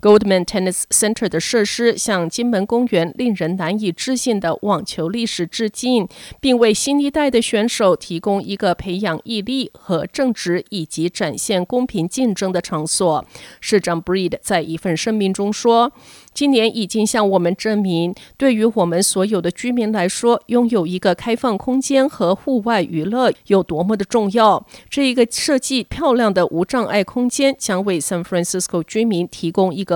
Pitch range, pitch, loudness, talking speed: 180-235 Hz, 210 Hz, -18 LUFS, 315 characters per minute